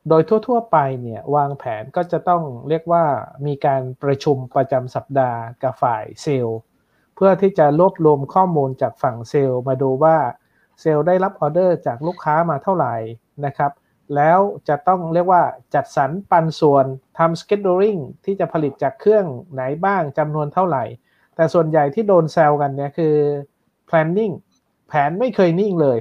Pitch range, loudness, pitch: 140-180 Hz, -18 LUFS, 155 Hz